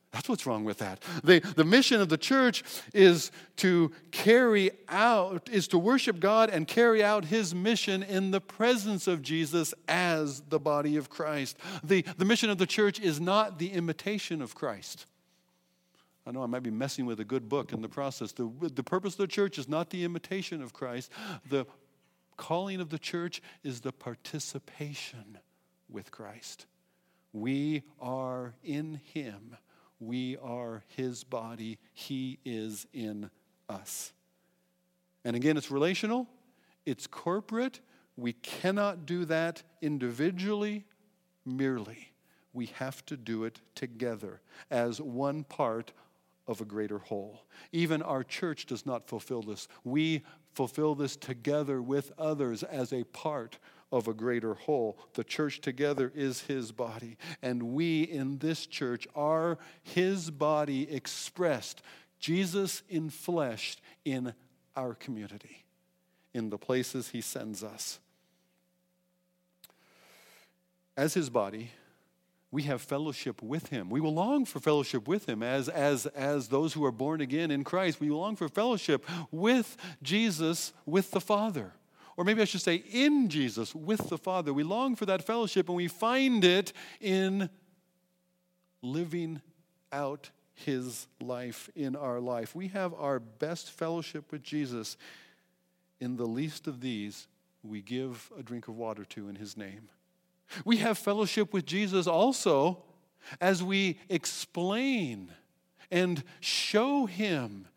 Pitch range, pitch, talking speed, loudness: 130-180 Hz, 155 Hz, 145 wpm, -31 LUFS